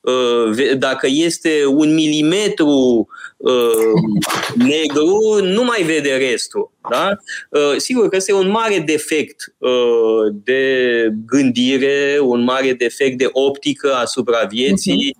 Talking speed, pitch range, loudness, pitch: 100 wpm, 125-185 Hz, -15 LUFS, 140 Hz